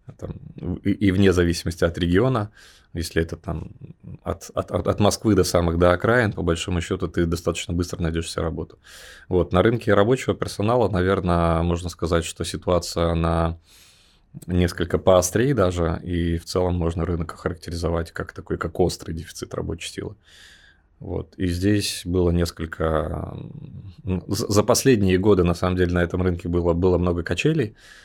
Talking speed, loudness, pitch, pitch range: 150 wpm, -22 LUFS, 90 Hz, 85-100 Hz